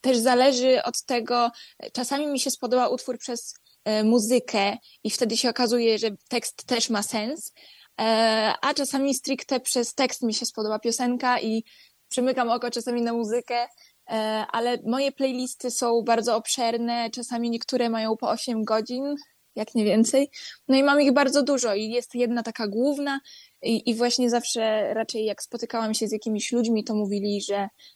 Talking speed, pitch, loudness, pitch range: 160 wpm, 240 Hz, -25 LUFS, 225-255 Hz